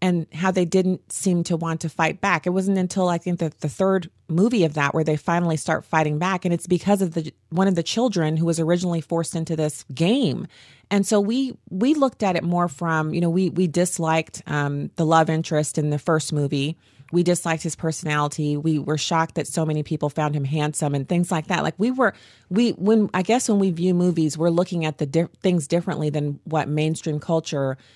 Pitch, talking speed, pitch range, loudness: 165 Hz, 225 wpm, 155-185 Hz, -22 LUFS